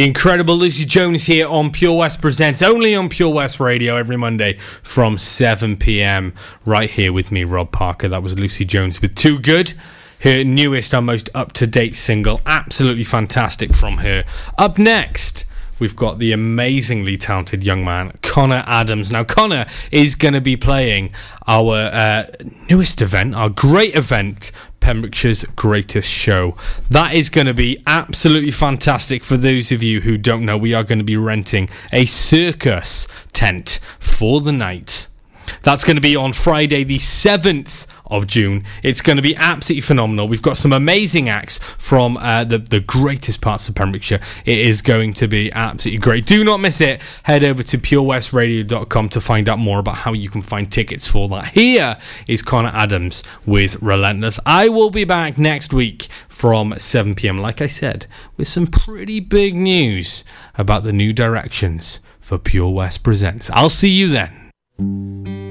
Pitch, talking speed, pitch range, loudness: 115 Hz, 170 wpm, 105-145 Hz, -15 LUFS